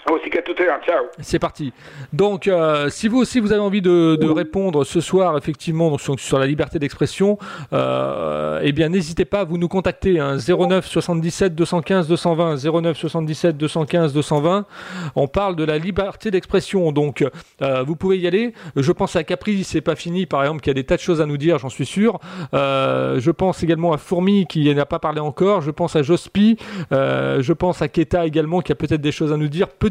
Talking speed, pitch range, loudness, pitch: 205 wpm, 150-185 Hz, -19 LUFS, 170 Hz